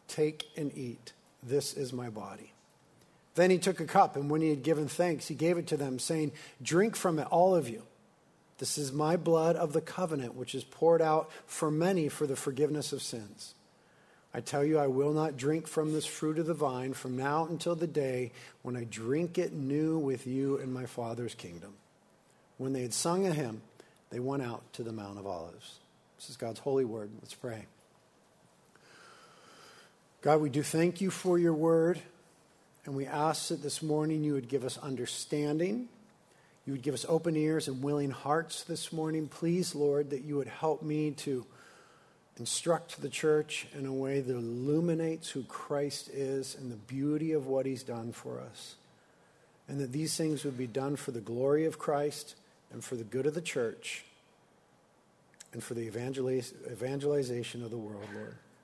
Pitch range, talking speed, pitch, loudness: 130-160 Hz, 190 wpm, 145 Hz, -33 LUFS